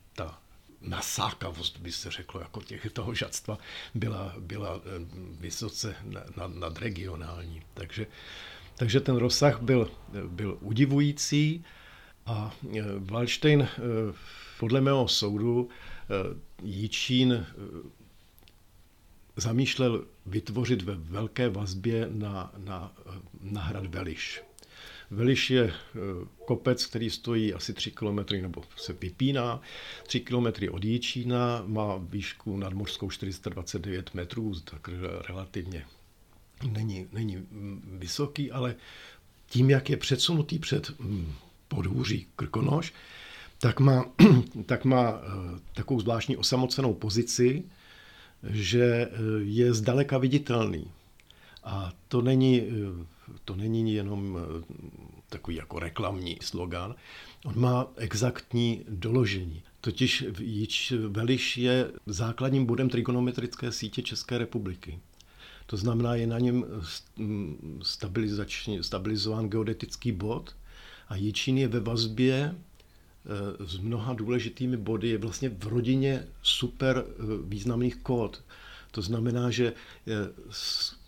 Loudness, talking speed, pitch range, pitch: -29 LUFS, 100 wpm, 95-125 Hz, 110 Hz